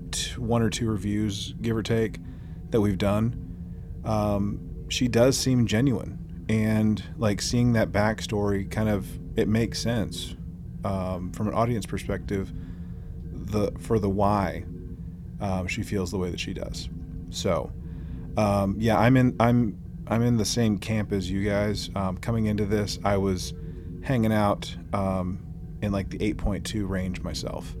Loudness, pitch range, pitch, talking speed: -26 LUFS, 90-110 Hz, 100 Hz, 155 wpm